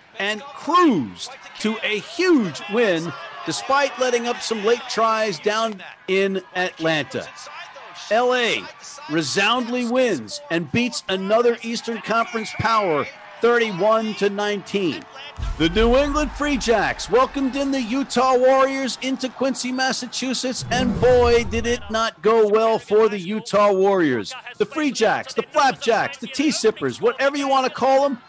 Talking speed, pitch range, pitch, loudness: 140 wpm, 210-260 Hz, 230 Hz, -20 LUFS